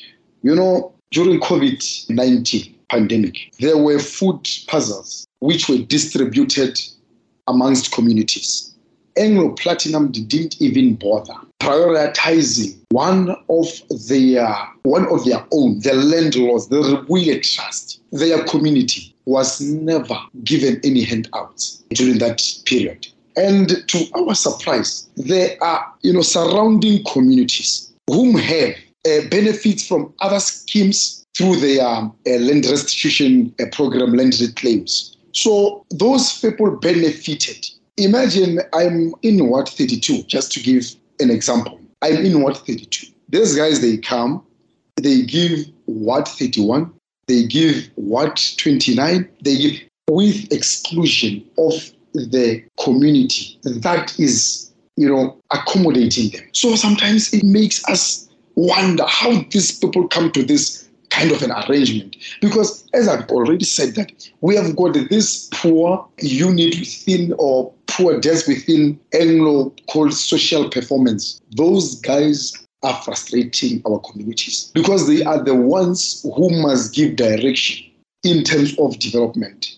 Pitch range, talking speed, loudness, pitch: 130-195 Hz, 125 wpm, -16 LUFS, 155 Hz